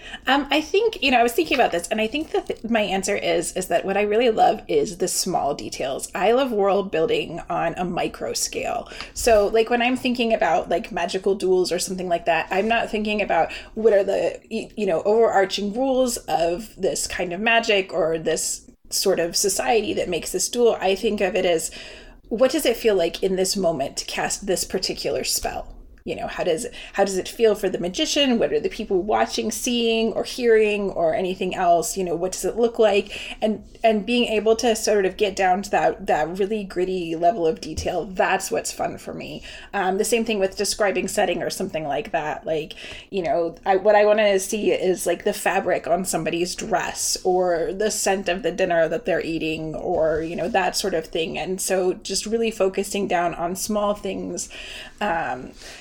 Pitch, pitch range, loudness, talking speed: 200 Hz, 180-225 Hz, -22 LUFS, 210 wpm